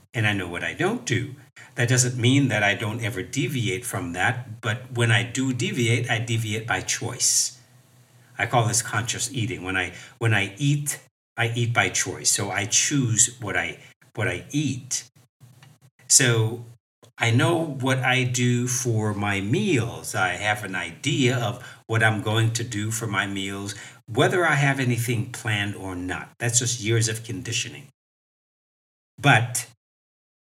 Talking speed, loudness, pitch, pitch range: 165 wpm, -23 LUFS, 120 Hz, 110-125 Hz